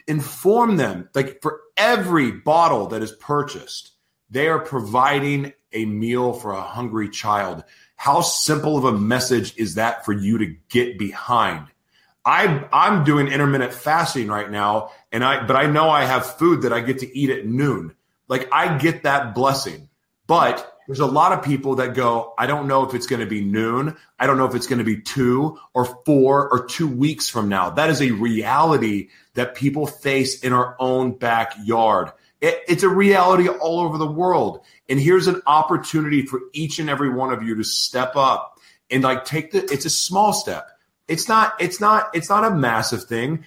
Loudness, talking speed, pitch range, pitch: -19 LUFS, 190 wpm, 120-155 Hz, 135 Hz